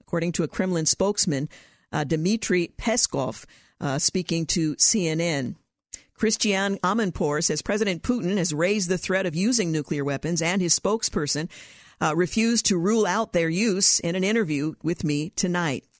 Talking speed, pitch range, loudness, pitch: 155 wpm, 160-205 Hz, -23 LUFS, 180 Hz